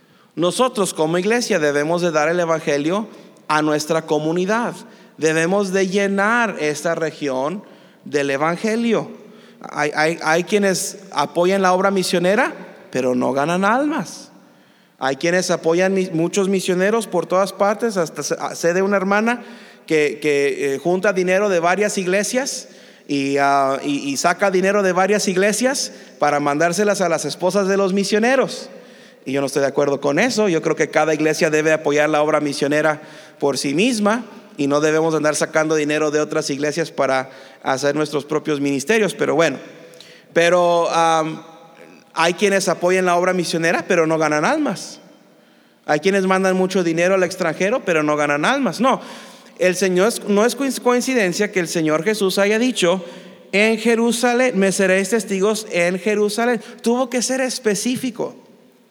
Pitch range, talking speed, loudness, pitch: 155-210 Hz, 155 wpm, -18 LUFS, 180 Hz